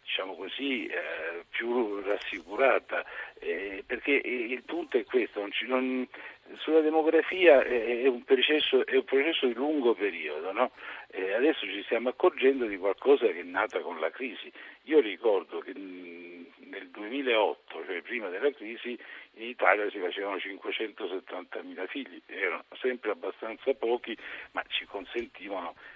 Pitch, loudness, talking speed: 385 Hz, -29 LUFS, 145 wpm